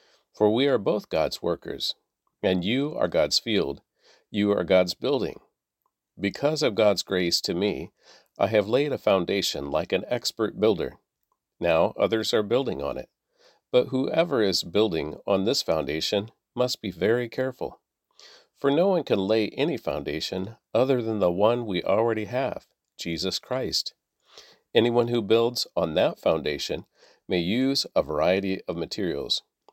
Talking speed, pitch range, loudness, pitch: 150 wpm, 95-125 Hz, -25 LUFS, 110 Hz